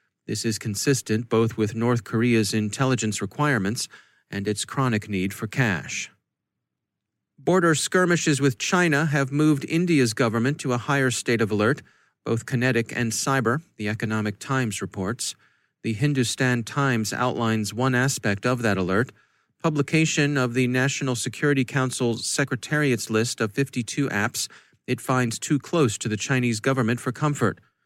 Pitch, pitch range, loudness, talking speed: 125 Hz, 110-140 Hz, -24 LUFS, 145 wpm